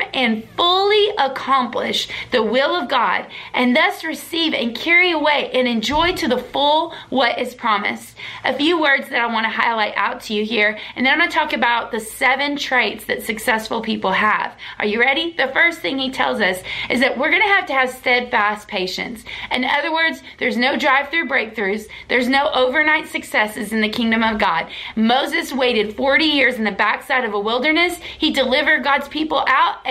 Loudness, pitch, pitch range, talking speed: -17 LUFS, 265 Hz, 230-305 Hz, 200 wpm